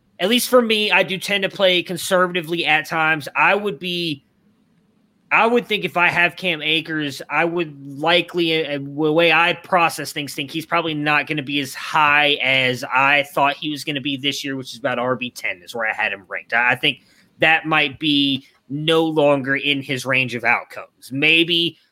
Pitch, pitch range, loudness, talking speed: 155 Hz, 140-175 Hz, -18 LUFS, 205 wpm